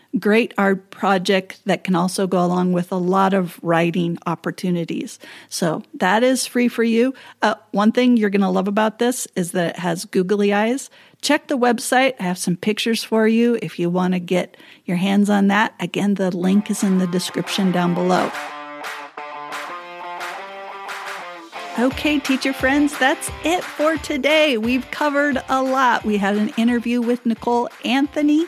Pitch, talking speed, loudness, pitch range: 205 Hz, 170 wpm, -19 LUFS, 180-245 Hz